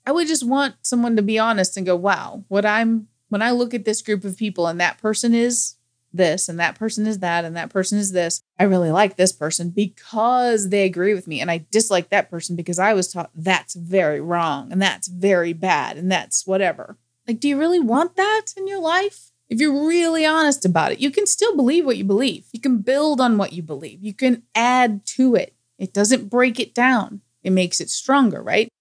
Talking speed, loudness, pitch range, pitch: 225 wpm, -19 LUFS, 185-245 Hz, 210 Hz